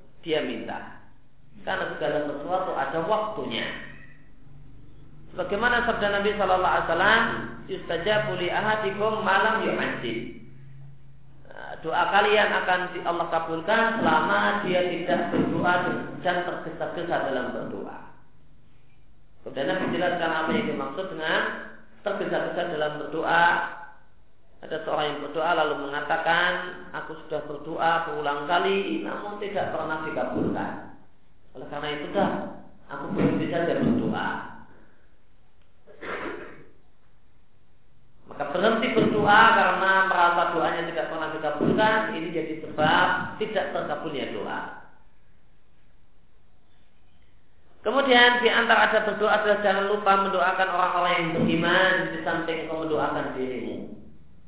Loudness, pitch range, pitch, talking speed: -24 LUFS, 150-190 Hz, 170 Hz, 100 wpm